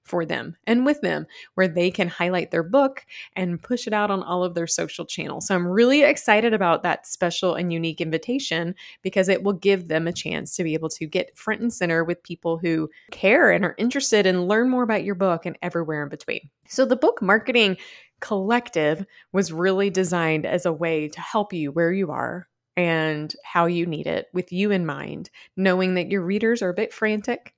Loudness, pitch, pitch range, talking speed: -23 LUFS, 180 Hz, 170-215 Hz, 210 wpm